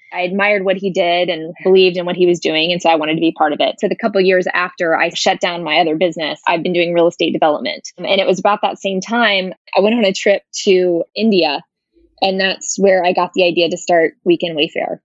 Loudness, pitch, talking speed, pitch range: -15 LUFS, 185 Hz, 255 wpm, 175-195 Hz